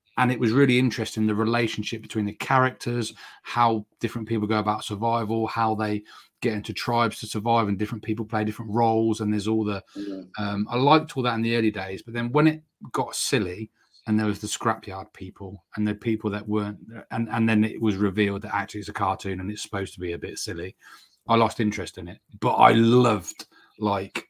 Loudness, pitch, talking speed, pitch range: -25 LUFS, 110 Hz, 215 wpm, 105-115 Hz